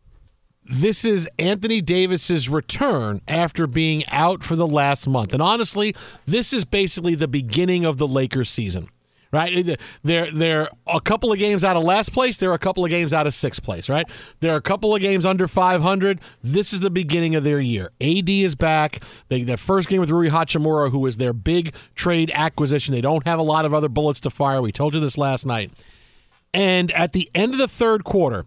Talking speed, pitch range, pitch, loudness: 205 wpm, 145-185 Hz, 165 Hz, -20 LUFS